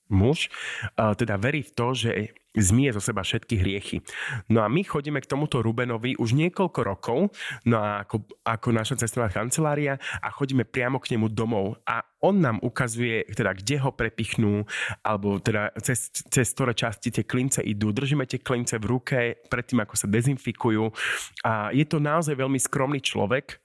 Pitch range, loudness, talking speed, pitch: 110-135 Hz, -26 LUFS, 170 wpm, 120 Hz